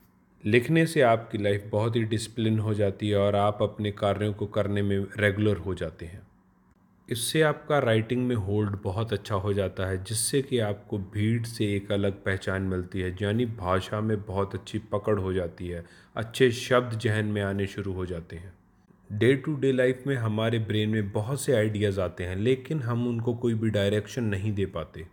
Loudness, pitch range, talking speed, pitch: -27 LUFS, 100-115 Hz, 195 wpm, 105 Hz